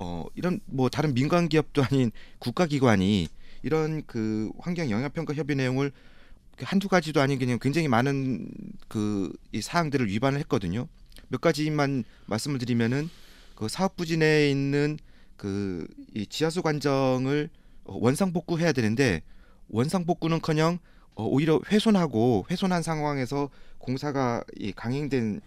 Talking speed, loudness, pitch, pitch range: 290 characters per minute, -27 LUFS, 140 Hz, 120-165 Hz